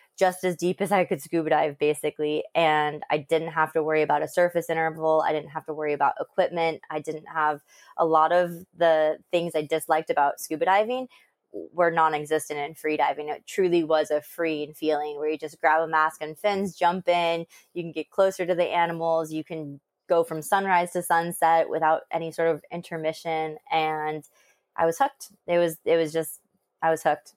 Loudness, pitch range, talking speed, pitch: -25 LUFS, 155-170 Hz, 200 wpm, 160 Hz